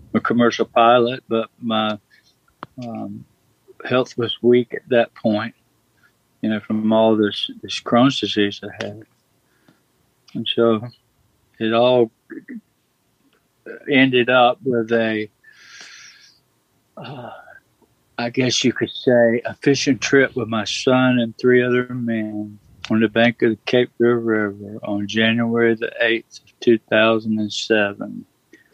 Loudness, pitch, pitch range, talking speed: -18 LUFS, 115 Hz, 110-125 Hz, 125 wpm